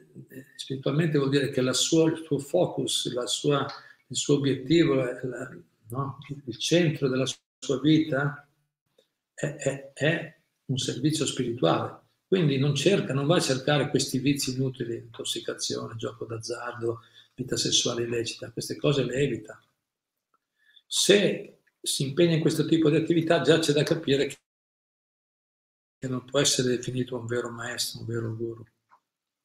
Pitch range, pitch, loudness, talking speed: 125-150 Hz, 135 Hz, -26 LUFS, 145 wpm